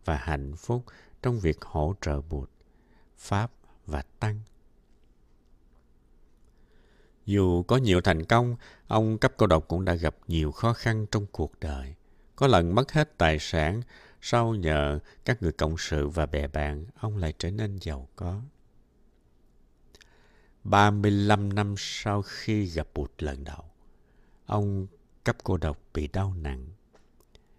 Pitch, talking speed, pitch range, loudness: 85 Hz, 140 wpm, 75-105 Hz, -28 LUFS